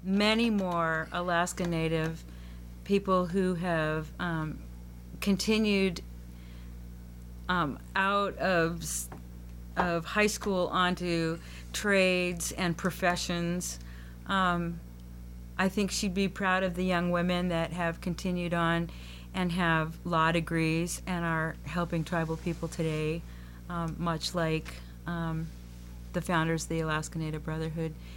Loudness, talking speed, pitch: -30 LUFS, 115 wpm, 165 Hz